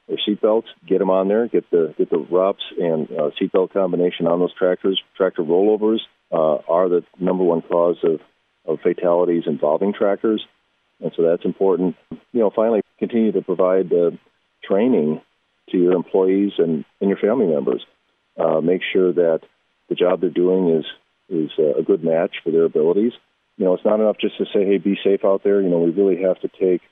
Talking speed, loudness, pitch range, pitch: 200 wpm, -19 LUFS, 90-105 Hz, 95 Hz